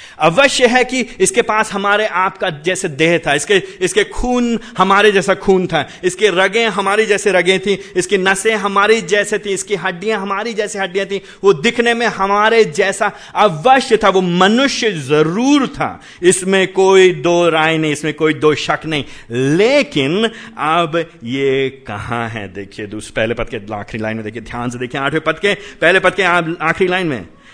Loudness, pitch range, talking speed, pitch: -14 LUFS, 155-210 Hz, 175 wpm, 190 Hz